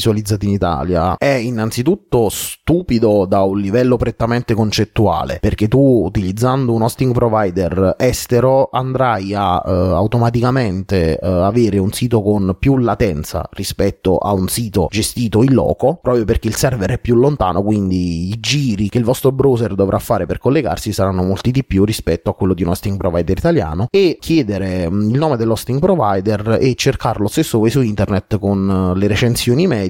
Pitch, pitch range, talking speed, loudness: 110 Hz, 95-125 Hz, 165 wpm, -15 LUFS